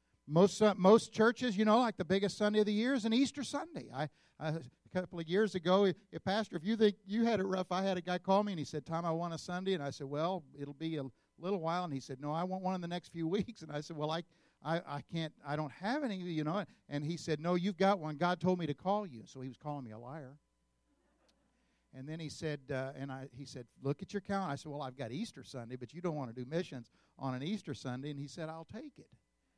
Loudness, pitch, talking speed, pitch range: -36 LUFS, 165 Hz, 285 wpm, 145-195 Hz